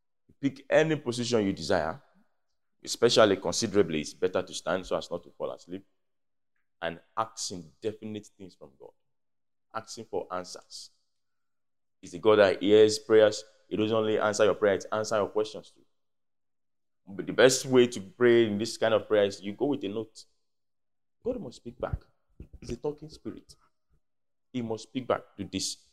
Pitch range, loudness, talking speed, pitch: 95-120 Hz, -27 LUFS, 170 wpm, 110 Hz